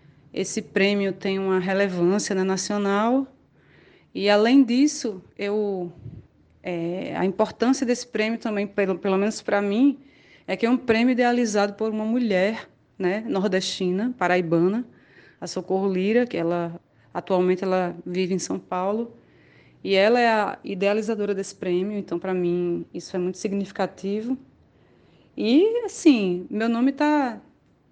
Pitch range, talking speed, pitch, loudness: 185-230 Hz, 140 wpm, 200 Hz, -23 LUFS